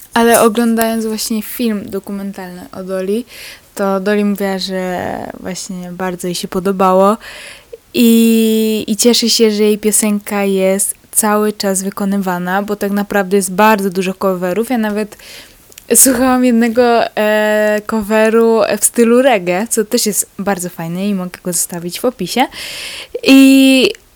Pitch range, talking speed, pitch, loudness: 195-230 Hz, 135 wpm, 210 Hz, -13 LUFS